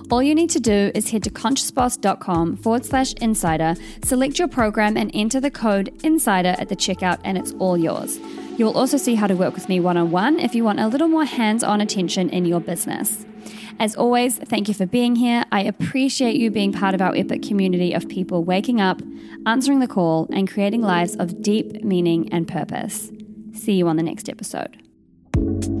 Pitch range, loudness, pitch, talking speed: 185-245 Hz, -20 LUFS, 215 Hz, 205 wpm